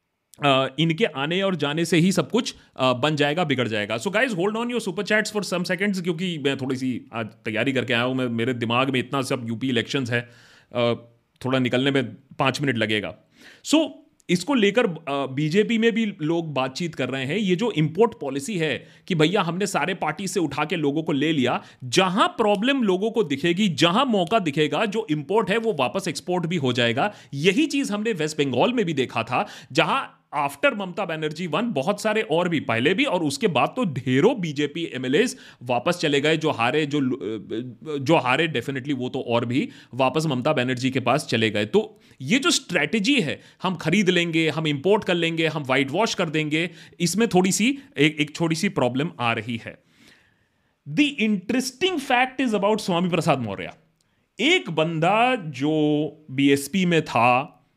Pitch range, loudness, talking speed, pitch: 130-205 Hz, -23 LUFS, 190 wpm, 155 Hz